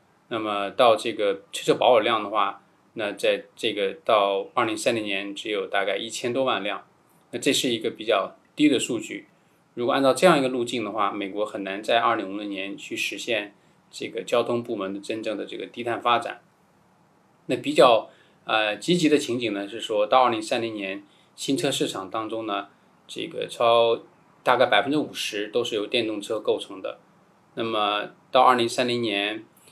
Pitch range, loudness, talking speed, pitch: 105-150 Hz, -24 LUFS, 275 characters per minute, 115 Hz